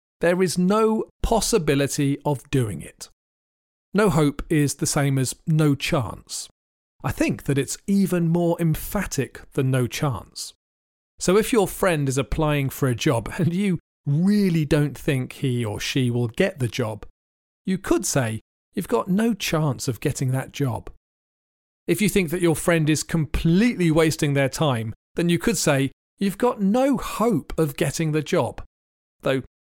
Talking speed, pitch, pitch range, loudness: 165 wpm, 150 Hz, 125-175 Hz, -23 LUFS